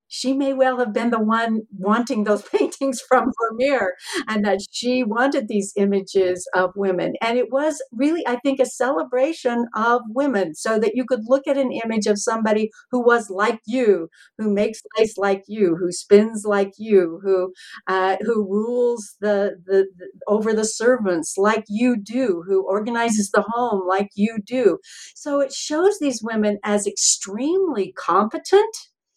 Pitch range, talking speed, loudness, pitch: 200-250 Hz, 165 wpm, -21 LUFS, 220 Hz